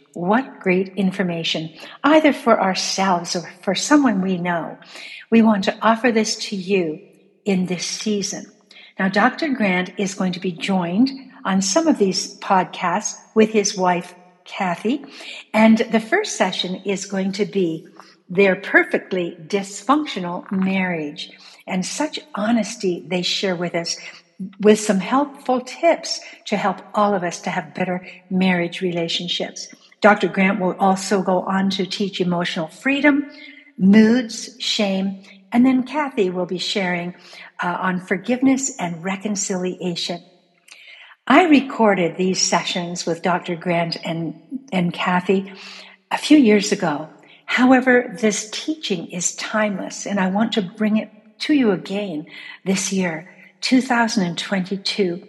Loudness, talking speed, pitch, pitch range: -20 LUFS, 135 wpm, 195 Hz, 180-225 Hz